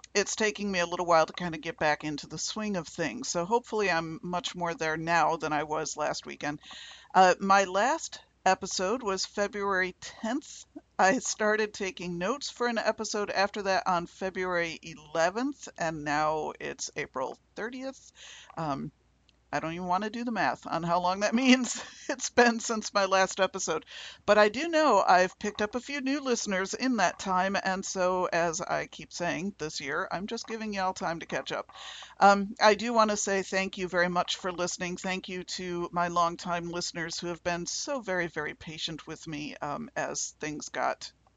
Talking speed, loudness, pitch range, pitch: 195 wpm, -29 LUFS, 170-215 Hz, 185 Hz